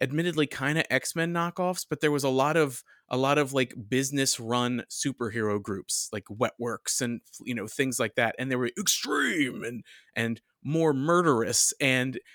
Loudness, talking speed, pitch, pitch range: -27 LUFS, 175 wpm, 130 Hz, 120-150 Hz